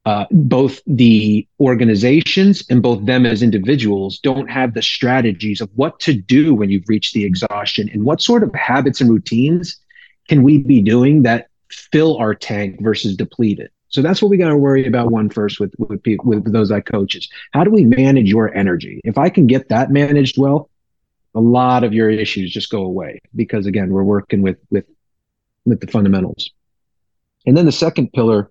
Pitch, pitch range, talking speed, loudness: 115 Hz, 105-135 Hz, 195 wpm, -14 LUFS